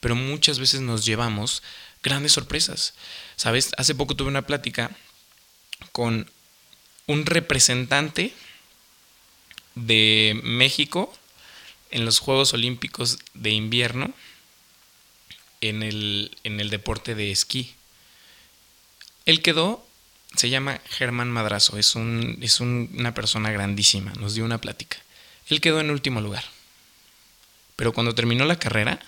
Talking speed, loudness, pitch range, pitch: 120 wpm, -22 LUFS, 110-135 Hz, 120 Hz